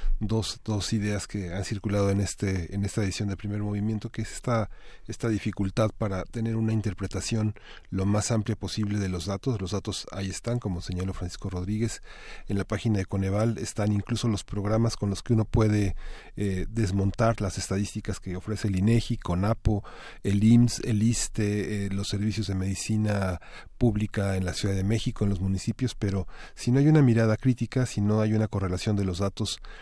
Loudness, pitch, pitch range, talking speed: -28 LUFS, 105 Hz, 100-110 Hz, 190 wpm